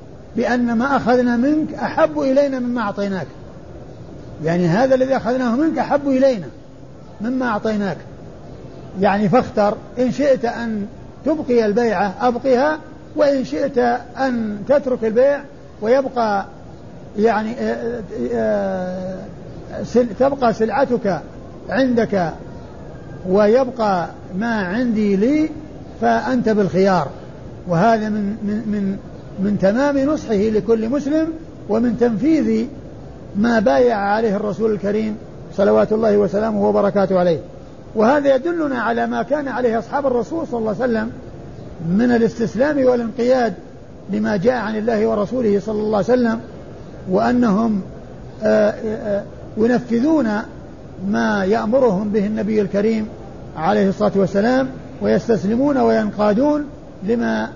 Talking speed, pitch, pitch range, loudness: 105 wpm, 225 Hz, 205-250 Hz, -18 LUFS